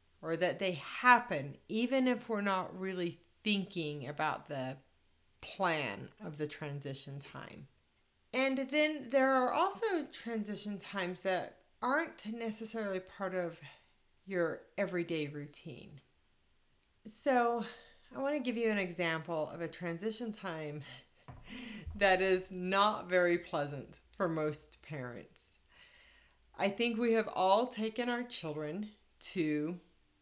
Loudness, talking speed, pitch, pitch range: -35 LUFS, 120 wpm, 190 Hz, 155-230 Hz